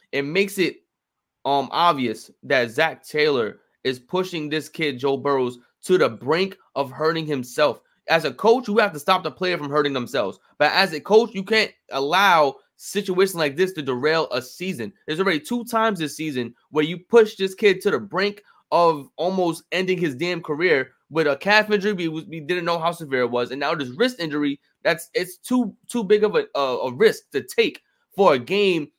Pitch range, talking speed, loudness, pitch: 150-205 Hz, 200 wpm, -22 LUFS, 175 Hz